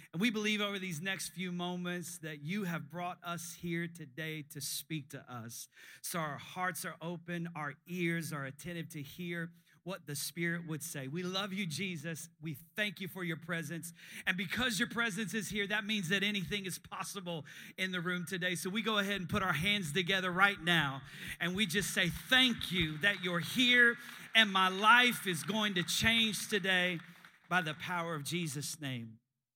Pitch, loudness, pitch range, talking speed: 175 Hz, -34 LUFS, 160-200 Hz, 195 wpm